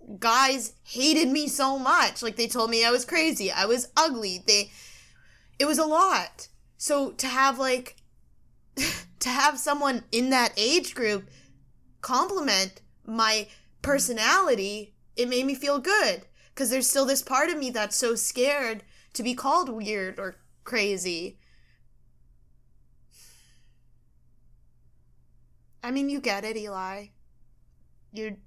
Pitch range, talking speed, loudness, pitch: 200-275 Hz, 130 wpm, -25 LUFS, 235 Hz